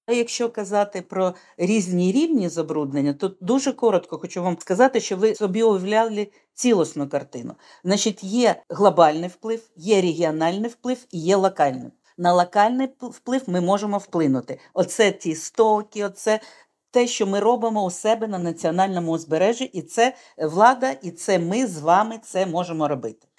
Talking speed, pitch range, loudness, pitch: 150 wpm, 175-225 Hz, -22 LUFS, 200 Hz